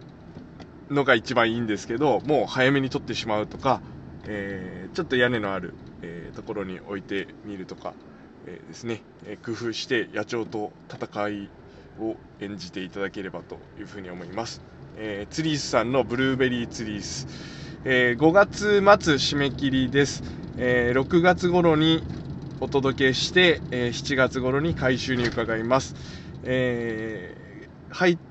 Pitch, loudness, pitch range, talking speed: 120 Hz, -24 LUFS, 105-140 Hz, 295 characters per minute